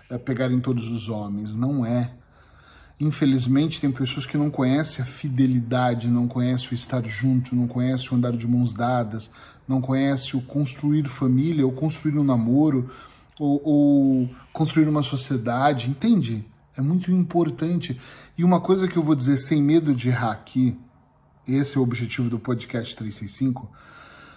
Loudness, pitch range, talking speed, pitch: -23 LUFS, 120-145 Hz, 160 wpm, 130 Hz